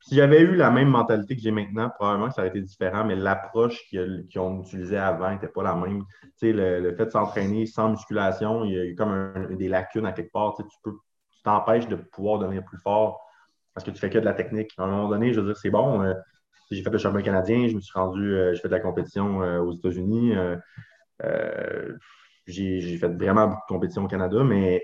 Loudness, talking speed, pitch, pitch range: -24 LUFS, 235 wpm, 100 Hz, 95-110 Hz